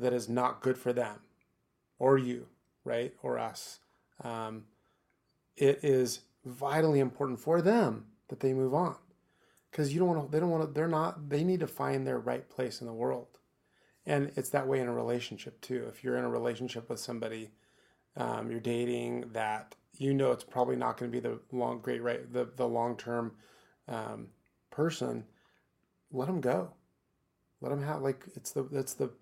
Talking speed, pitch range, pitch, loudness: 185 wpm, 115-140 Hz, 125 Hz, -33 LUFS